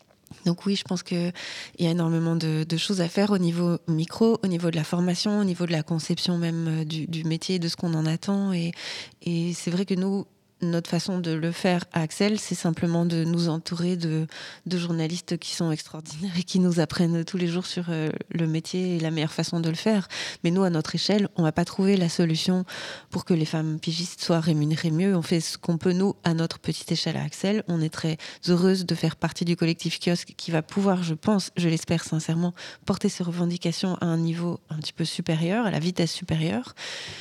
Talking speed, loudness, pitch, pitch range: 225 wpm, -26 LUFS, 170 Hz, 165-185 Hz